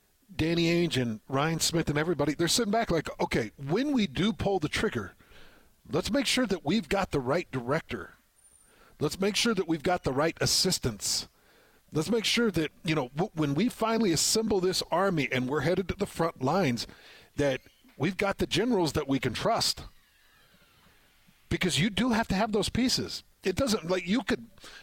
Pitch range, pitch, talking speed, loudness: 150-210 Hz, 170 Hz, 190 wpm, -28 LUFS